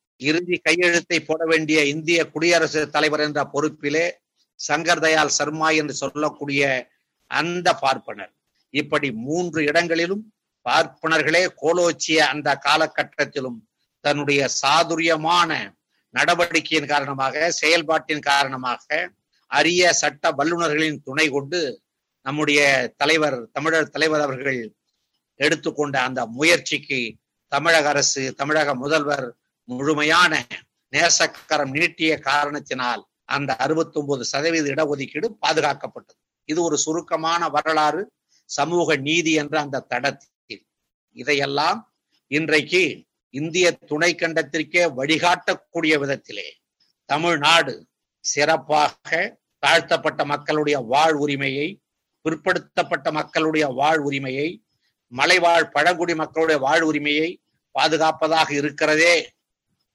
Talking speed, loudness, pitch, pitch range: 90 wpm, -20 LUFS, 155 Hz, 145-165 Hz